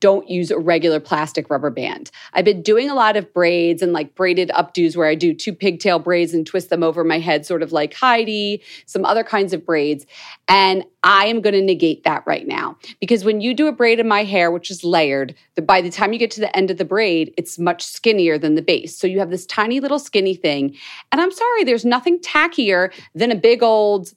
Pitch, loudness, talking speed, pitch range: 190 Hz, -17 LUFS, 235 wpm, 170-215 Hz